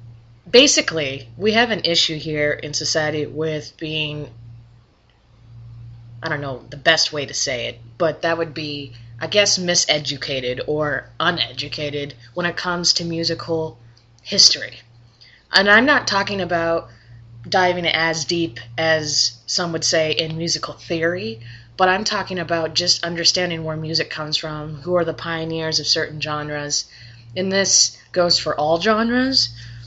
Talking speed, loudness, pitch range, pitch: 145 wpm, -19 LUFS, 120-170 Hz, 155 Hz